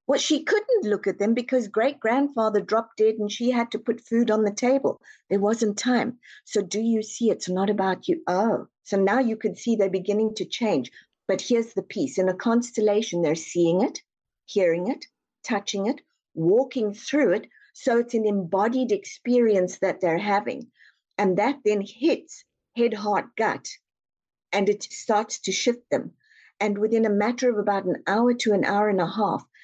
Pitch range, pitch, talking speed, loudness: 200-245 Hz, 220 Hz, 190 wpm, -24 LUFS